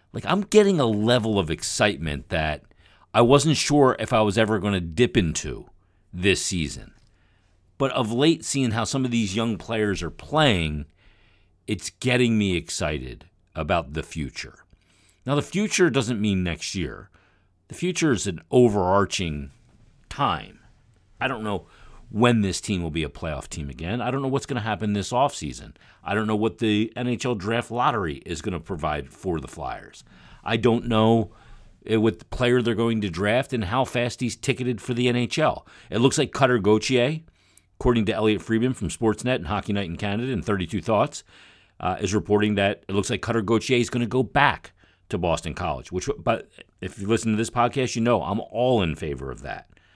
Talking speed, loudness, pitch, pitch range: 190 wpm, -24 LUFS, 110 Hz, 95-125 Hz